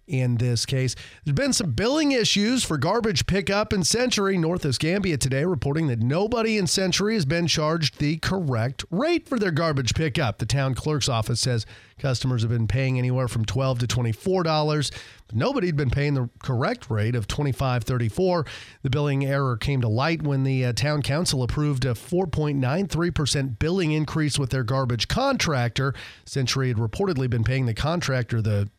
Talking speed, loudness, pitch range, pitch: 185 wpm, -24 LUFS, 125-165 Hz, 140 Hz